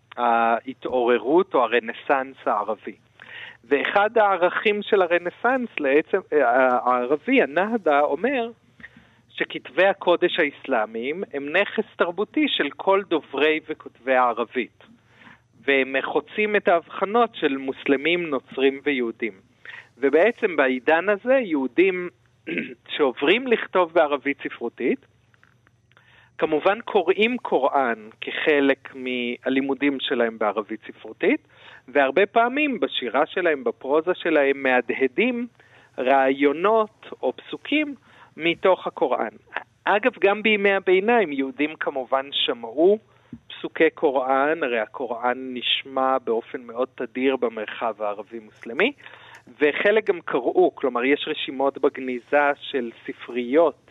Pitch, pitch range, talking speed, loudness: 145 Hz, 130-200 Hz, 95 wpm, -22 LUFS